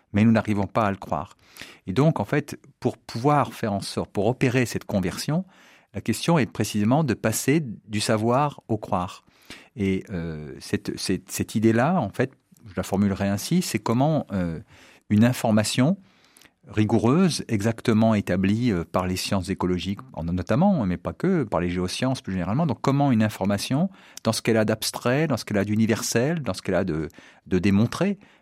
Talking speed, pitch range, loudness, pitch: 180 wpm, 100-130 Hz, -24 LUFS, 110 Hz